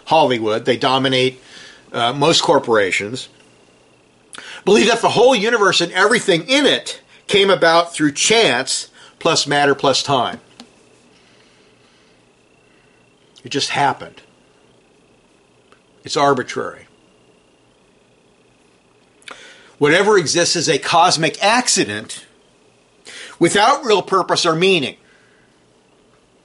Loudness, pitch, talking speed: -15 LUFS, 175 Hz, 90 wpm